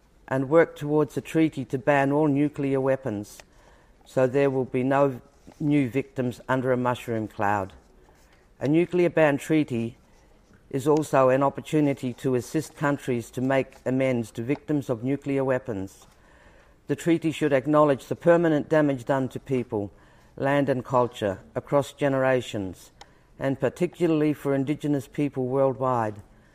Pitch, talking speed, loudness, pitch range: 135 Hz, 140 wpm, -25 LUFS, 125-145 Hz